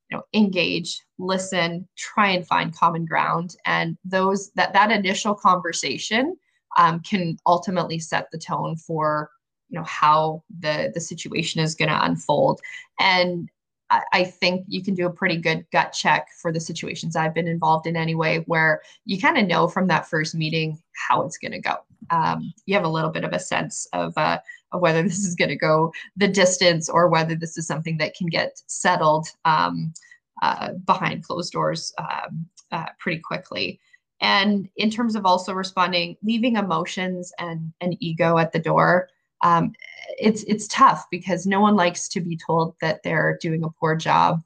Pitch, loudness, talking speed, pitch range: 175 Hz, -22 LUFS, 180 wpm, 165-195 Hz